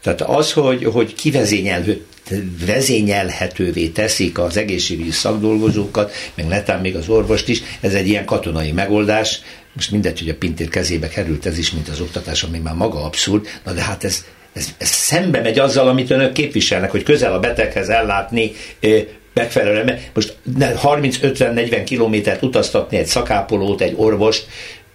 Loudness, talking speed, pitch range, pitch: -17 LUFS, 150 wpm, 90-110 Hz, 105 Hz